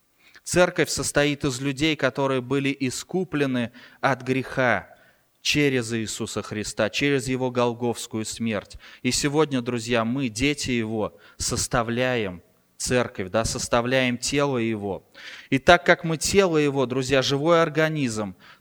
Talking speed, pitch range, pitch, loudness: 120 wpm, 115-145 Hz, 130 Hz, -24 LUFS